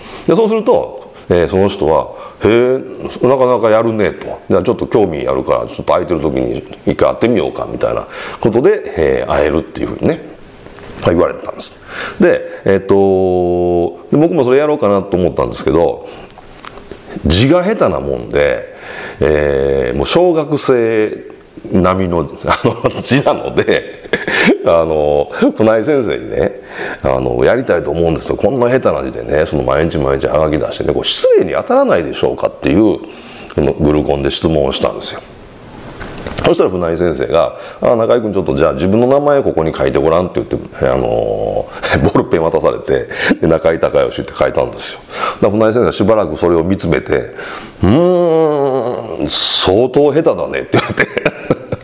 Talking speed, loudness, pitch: 345 characters per minute, -13 LUFS, 145 Hz